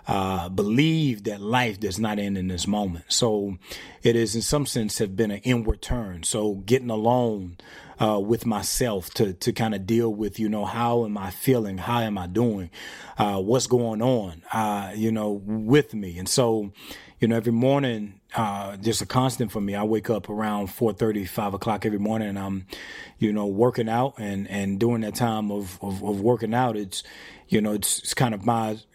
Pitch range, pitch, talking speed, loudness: 100-120 Hz, 110 Hz, 205 wpm, -25 LUFS